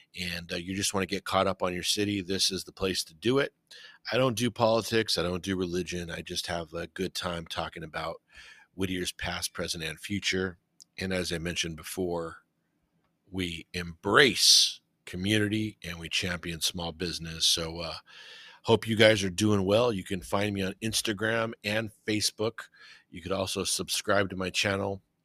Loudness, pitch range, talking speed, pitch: -28 LUFS, 85-105 Hz, 180 wpm, 95 Hz